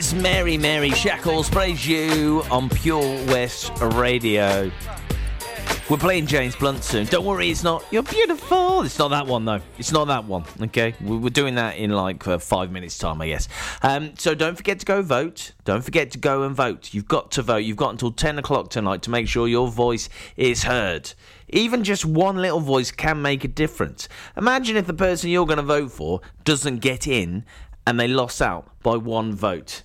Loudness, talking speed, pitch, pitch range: -22 LUFS, 200 wpm, 130 Hz, 110-160 Hz